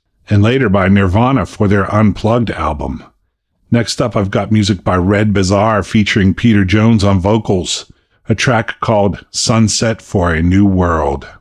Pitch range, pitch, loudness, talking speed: 95-110 Hz, 100 Hz, -13 LUFS, 155 wpm